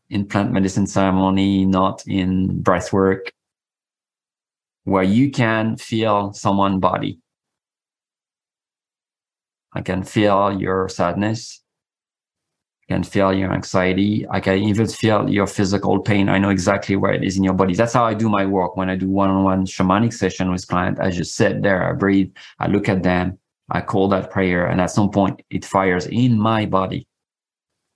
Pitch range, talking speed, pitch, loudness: 95-100 Hz, 170 wpm, 95 Hz, -19 LUFS